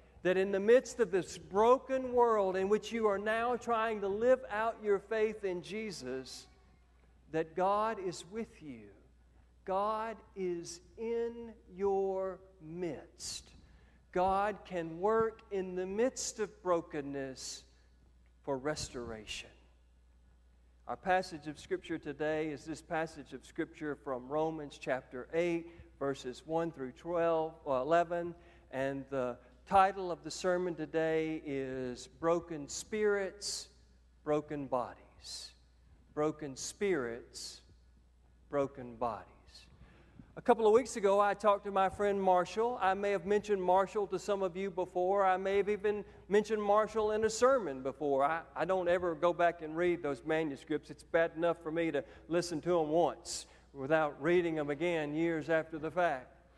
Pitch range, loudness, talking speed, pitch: 135-195 Hz, -34 LUFS, 145 wpm, 170 Hz